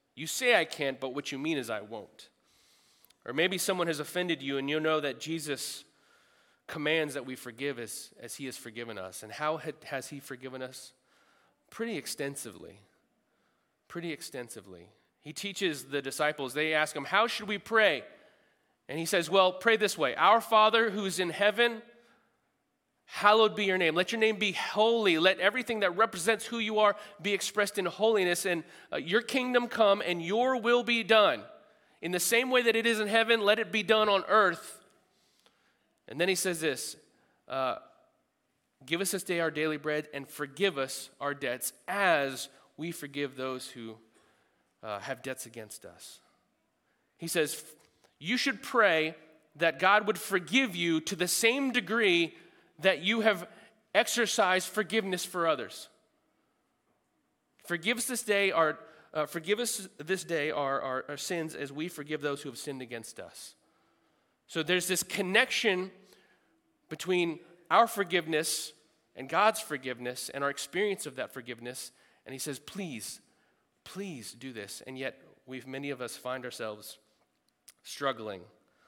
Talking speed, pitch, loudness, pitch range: 165 wpm, 170 Hz, -29 LUFS, 140-210 Hz